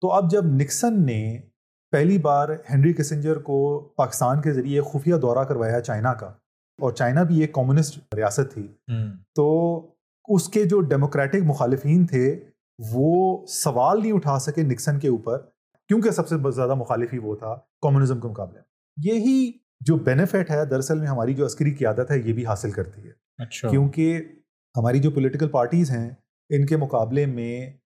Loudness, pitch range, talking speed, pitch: -22 LUFS, 125-160 Hz, 170 wpm, 145 Hz